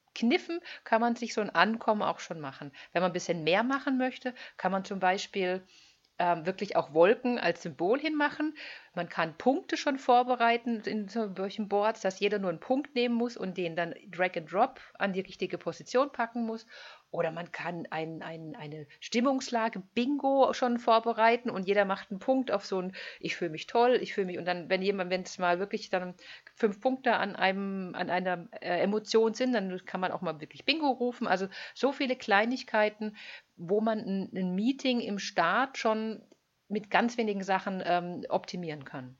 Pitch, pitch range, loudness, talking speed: 205 Hz, 180-240 Hz, -30 LUFS, 190 wpm